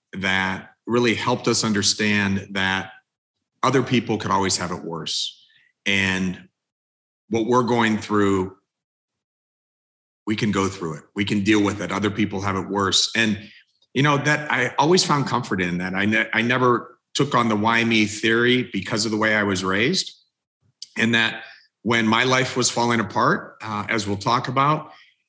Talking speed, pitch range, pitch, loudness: 175 wpm, 95-120 Hz, 110 Hz, -21 LUFS